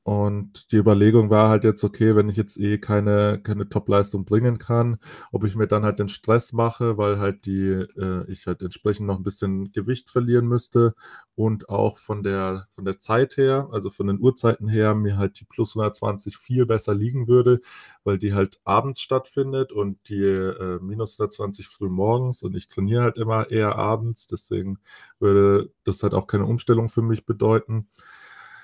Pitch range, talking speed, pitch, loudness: 100-115 Hz, 185 wpm, 105 Hz, -22 LUFS